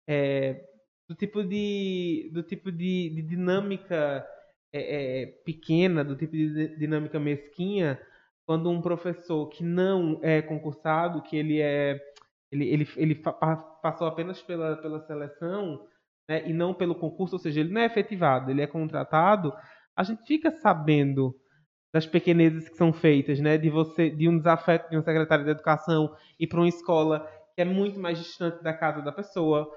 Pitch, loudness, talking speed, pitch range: 160 Hz, -27 LUFS, 170 wpm, 155-175 Hz